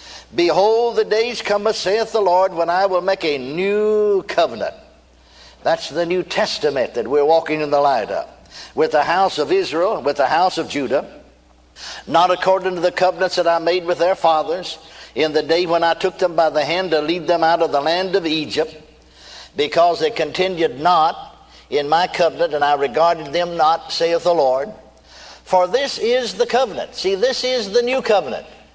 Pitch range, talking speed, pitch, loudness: 160-205 Hz, 190 wpm, 175 Hz, -18 LUFS